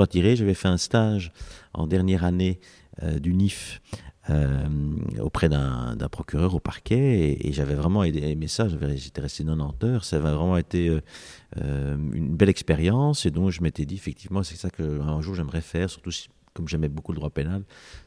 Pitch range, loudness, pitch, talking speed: 75-95 Hz, -25 LUFS, 85 Hz, 195 wpm